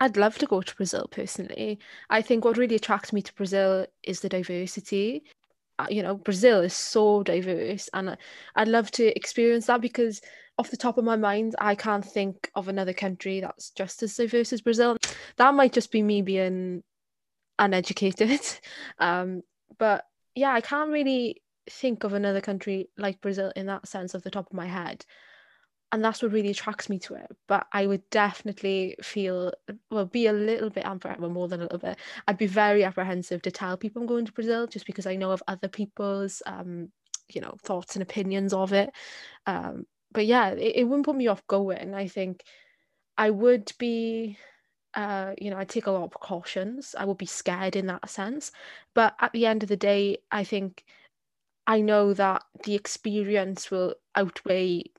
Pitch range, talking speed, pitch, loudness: 190-225 Hz, 190 wpm, 205 Hz, -27 LUFS